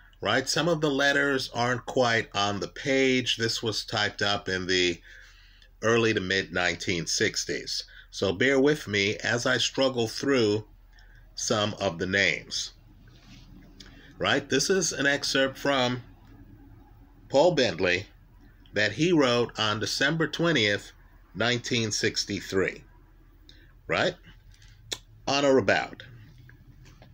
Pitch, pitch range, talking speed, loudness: 115 Hz, 100-135 Hz, 115 wpm, -26 LUFS